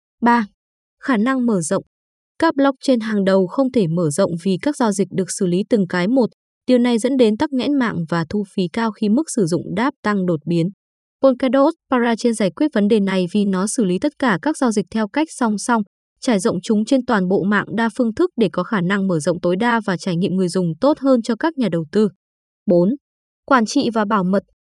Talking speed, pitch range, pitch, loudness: 240 wpm, 190-255 Hz, 220 Hz, -18 LUFS